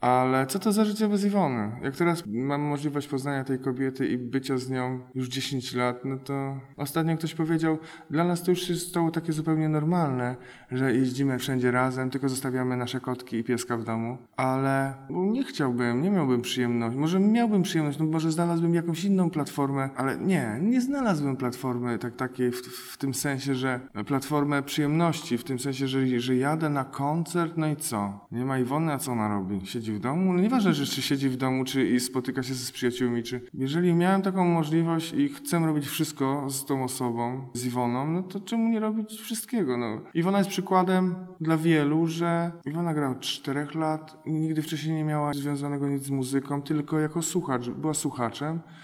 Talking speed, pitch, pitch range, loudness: 195 wpm, 140 Hz, 130-165 Hz, -27 LUFS